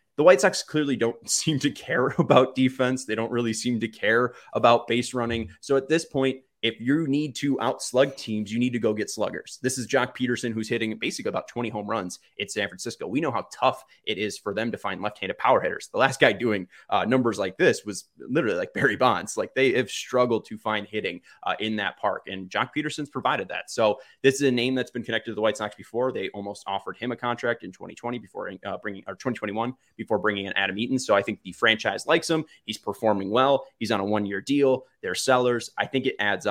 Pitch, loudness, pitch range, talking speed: 120 Hz, -25 LUFS, 110-130 Hz, 235 wpm